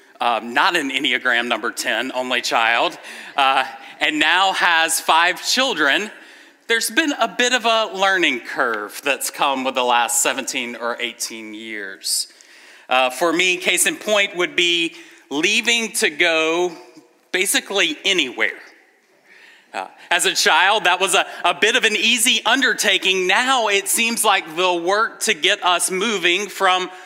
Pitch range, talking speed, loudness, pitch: 160-230 Hz, 150 wpm, -17 LUFS, 190 Hz